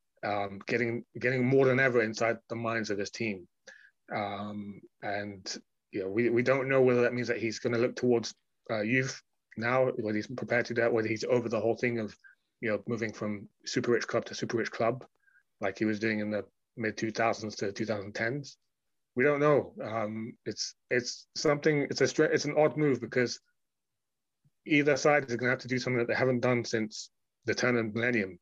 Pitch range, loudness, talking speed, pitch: 110-125 Hz, -30 LUFS, 205 wpm, 115 Hz